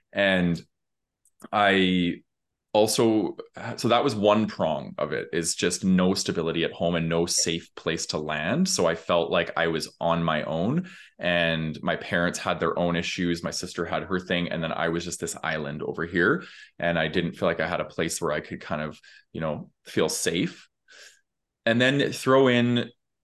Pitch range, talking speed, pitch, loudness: 85-115 Hz, 190 wpm, 90 Hz, -25 LUFS